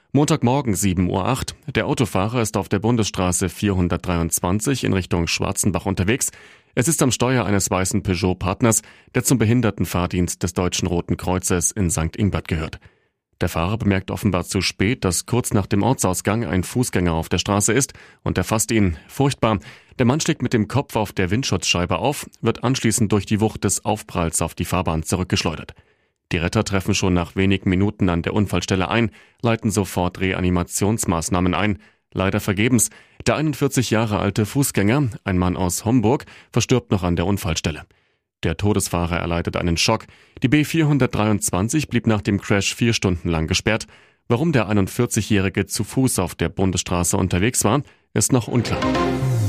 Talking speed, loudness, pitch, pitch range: 160 wpm, -20 LUFS, 100 Hz, 90-115 Hz